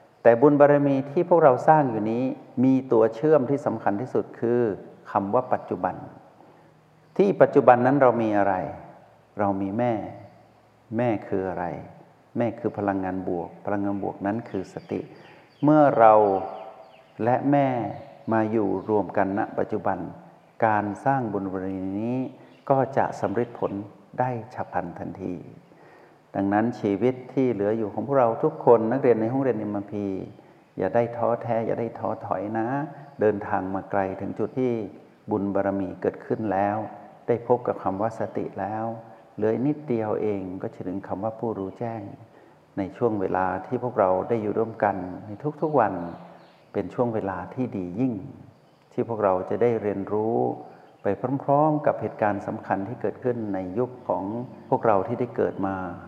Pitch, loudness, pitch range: 110 Hz, -25 LUFS, 100-125 Hz